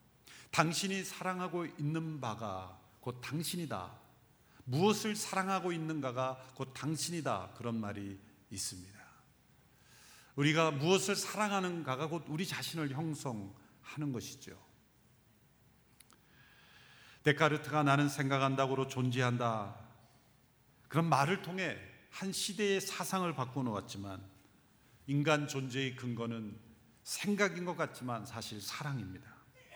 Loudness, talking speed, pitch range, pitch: -36 LUFS, 250 characters per minute, 115-165 Hz, 135 Hz